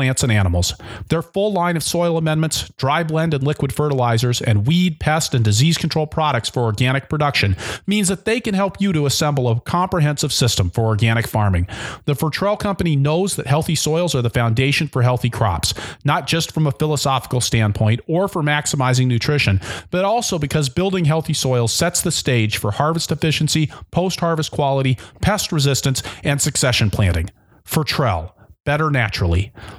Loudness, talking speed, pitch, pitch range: -18 LUFS, 165 wpm, 145 Hz, 115-160 Hz